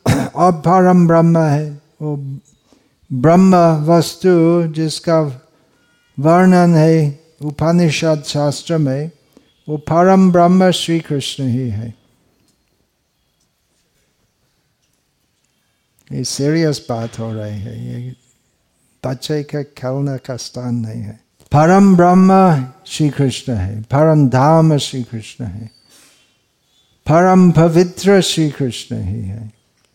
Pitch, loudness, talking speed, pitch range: 150 Hz, -14 LUFS, 95 wpm, 125-165 Hz